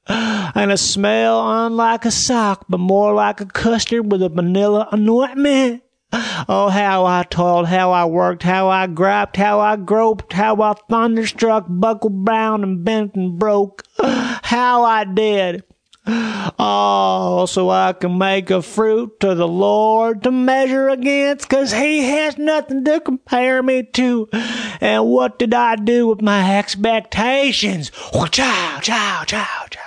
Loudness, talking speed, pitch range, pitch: -16 LUFS, 150 wpm, 190-235 Hz, 215 Hz